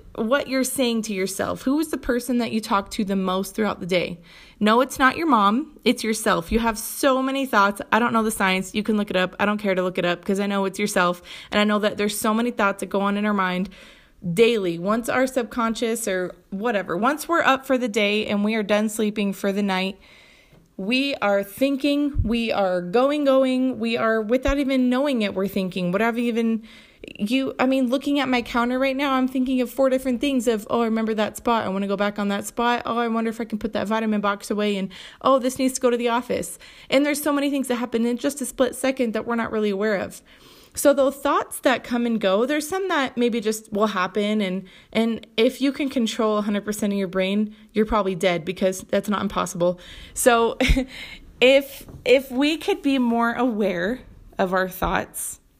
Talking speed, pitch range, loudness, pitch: 240 wpm, 200-260 Hz, -22 LUFS, 225 Hz